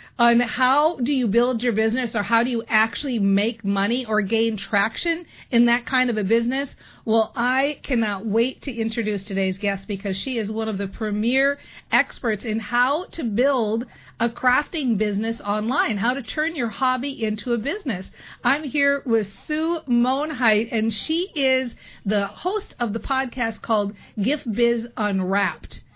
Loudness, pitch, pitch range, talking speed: -22 LUFS, 235 Hz, 215-260 Hz, 165 wpm